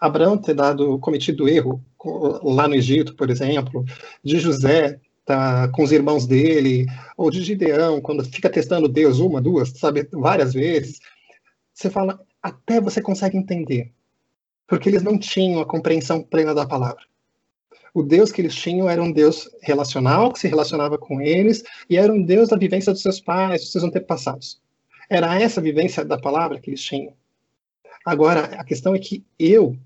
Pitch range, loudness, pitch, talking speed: 140-185 Hz, -19 LUFS, 155 Hz, 170 wpm